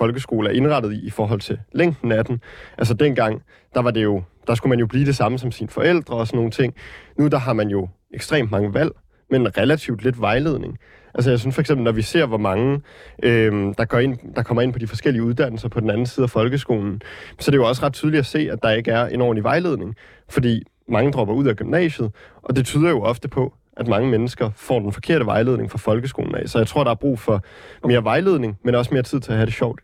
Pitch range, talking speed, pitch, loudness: 110-135 Hz, 255 wpm, 120 Hz, -20 LUFS